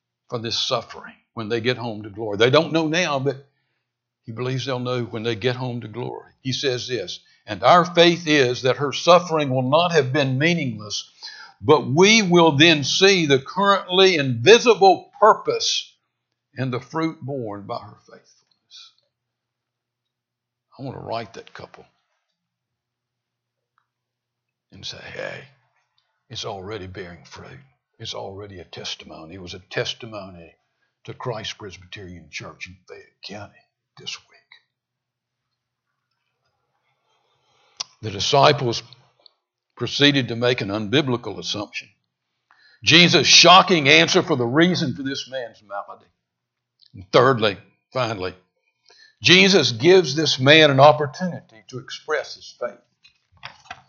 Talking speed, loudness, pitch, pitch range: 130 wpm, -17 LUFS, 130 Hz, 115-160 Hz